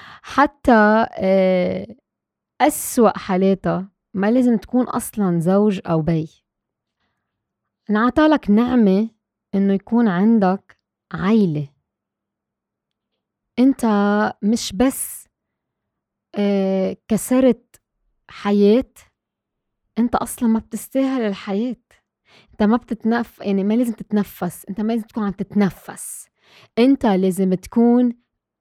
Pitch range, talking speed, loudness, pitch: 195-235 Hz, 90 wpm, -19 LUFS, 210 Hz